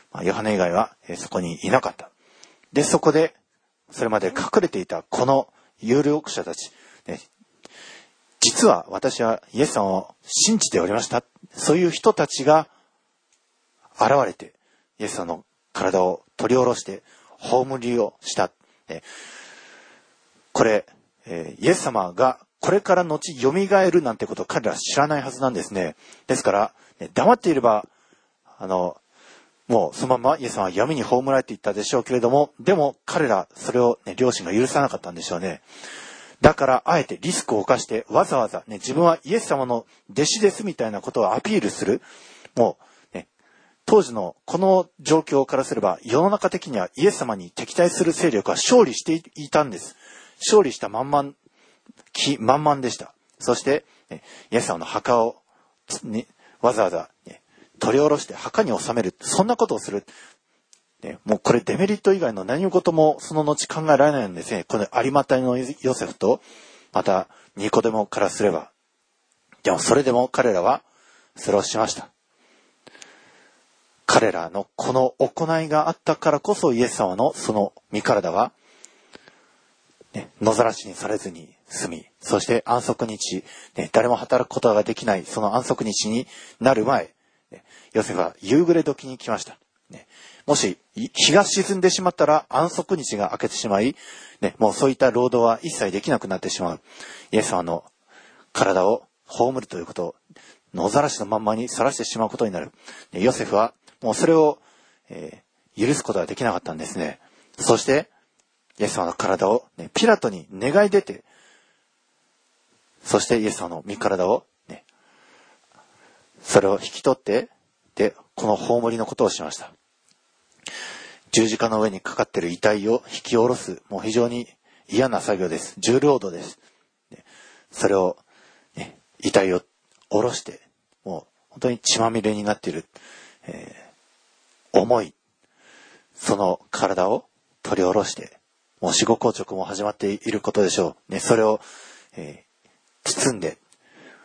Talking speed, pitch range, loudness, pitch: 300 characters per minute, 110-155 Hz, -22 LUFS, 130 Hz